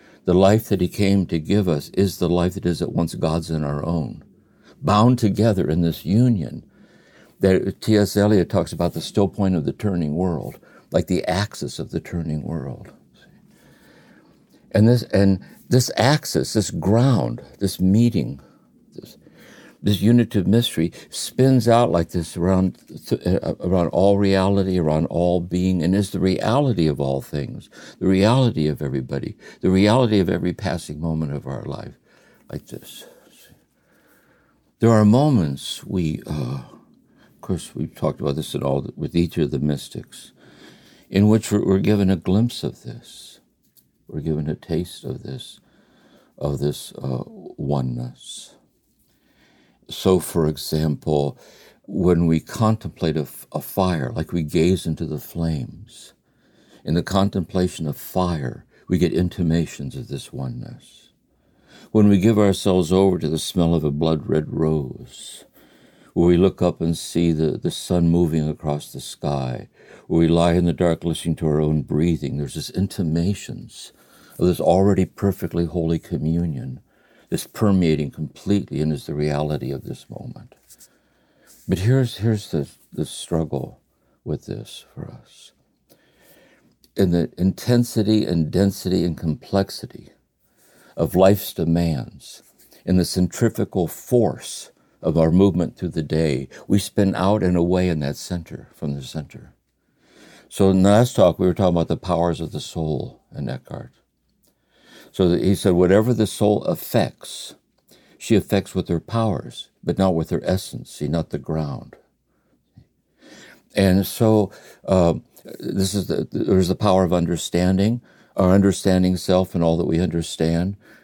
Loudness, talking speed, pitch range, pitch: -21 LUFS, 150 wpm, 80-100 Hz, 90 Hz